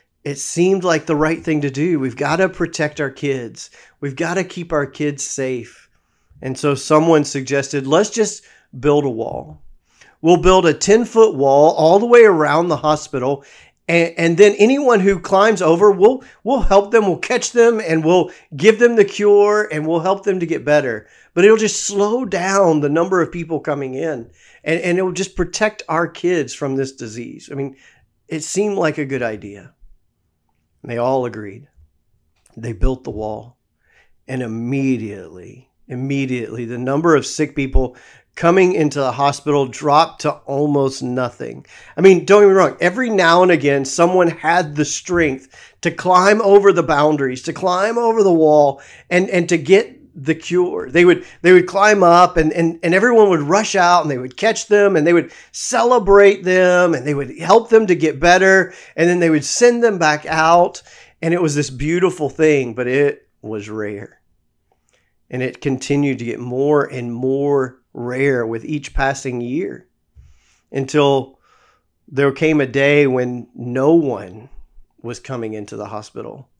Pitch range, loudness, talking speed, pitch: 135-180 Hz, -15 LUFS, 180 wpm, 155 Hz